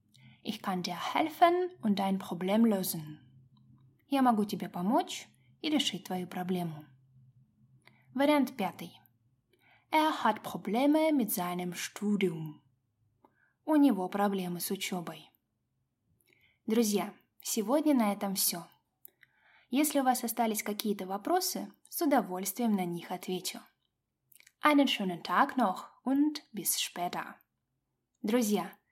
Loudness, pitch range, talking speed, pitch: -31 LUFS, 170-245 Hz, 110 wpm, 195 Hz